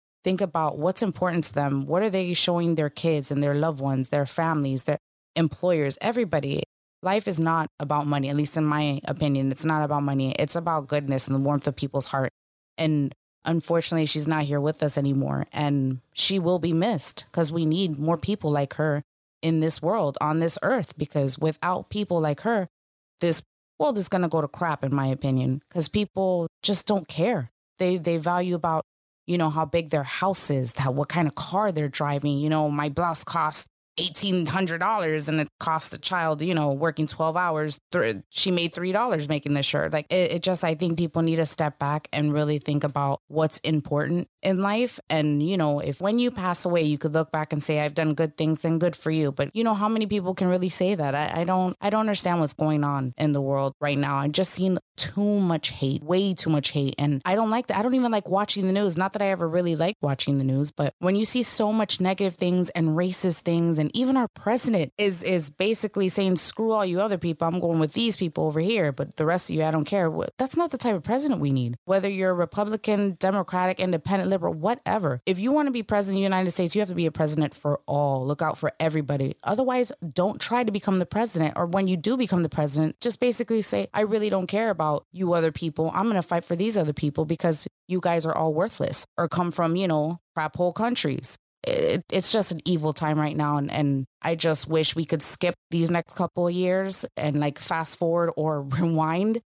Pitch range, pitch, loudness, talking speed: 150-190 Hz, 165 Hz, -25 LUFS, 230 wpm